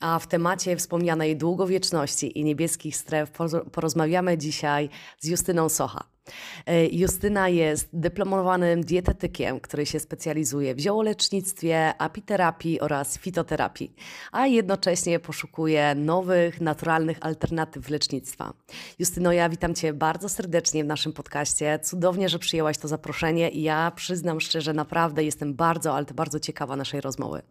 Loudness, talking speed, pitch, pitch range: -25 LUFS, 125 wpm, 165 Hz, 155-175 Hz